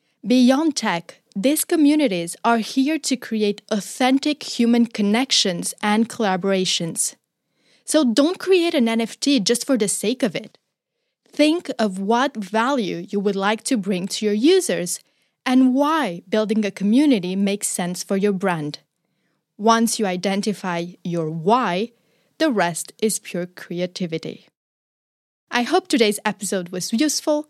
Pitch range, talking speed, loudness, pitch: 190-265 Hz, 135 wpm, -20 LUFS, 220 Hz